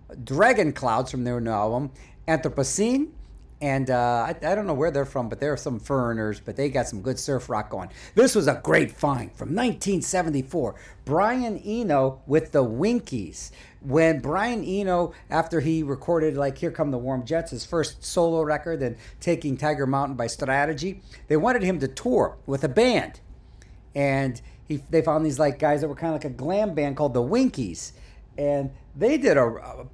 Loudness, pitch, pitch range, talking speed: -24 LUFS, 145 Hz, 130-165 Hz, 190 wpm